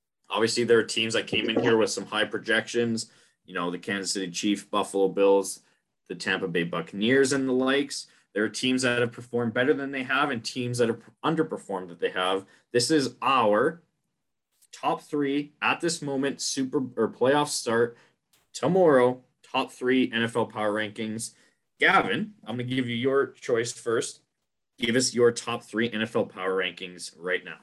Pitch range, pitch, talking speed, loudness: 110-135 Hz, 120 Hz, 180 wpm, -26 LUFS